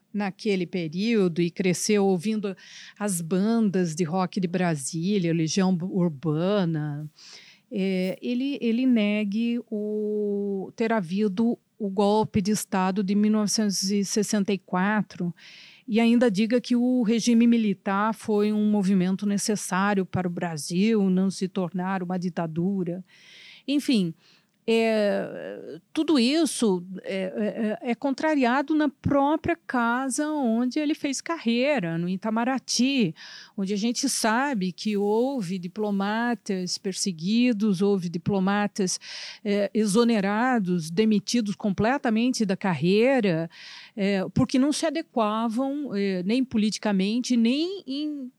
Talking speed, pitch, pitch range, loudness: 110 wpm, 210 Hz, 190-235 Hz, -25 LUFS